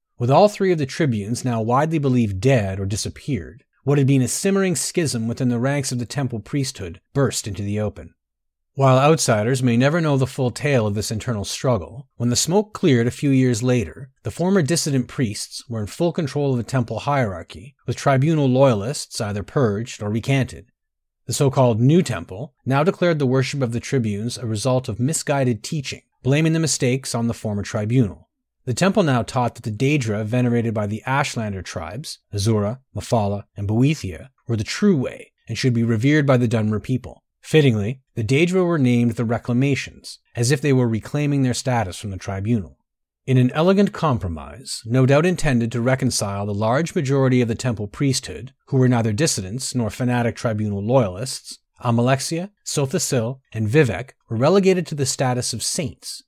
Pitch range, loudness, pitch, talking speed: 110-140 Hz, -21 LUFS, 125 Hz, 185 wpm